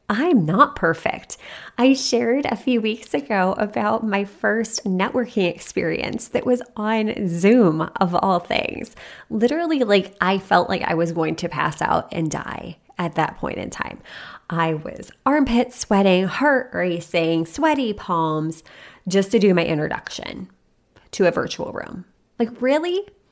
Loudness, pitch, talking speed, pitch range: -21 LUFS, 210 Hz, 150 wpm, 180-245 Hz